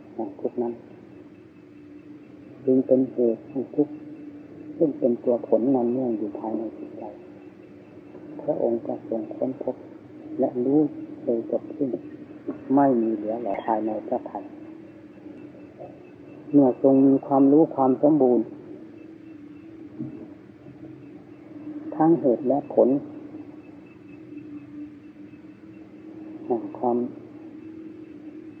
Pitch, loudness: 305 Hz, -24 LUFS